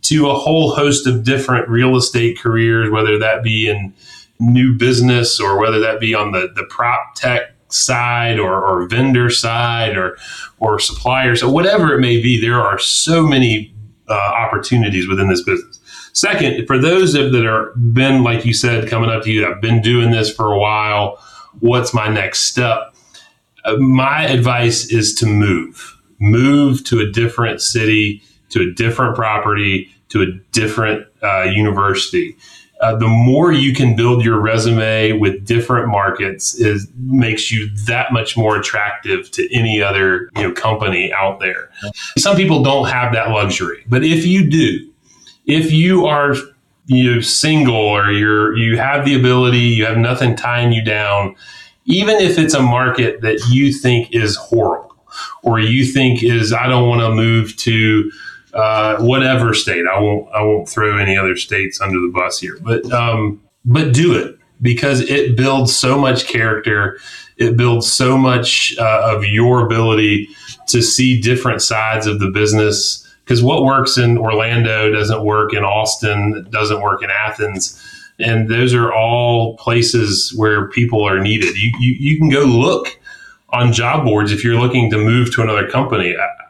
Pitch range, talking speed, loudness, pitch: 105-125 Hz, 170 wpm, -14 LUFS, 115 Hz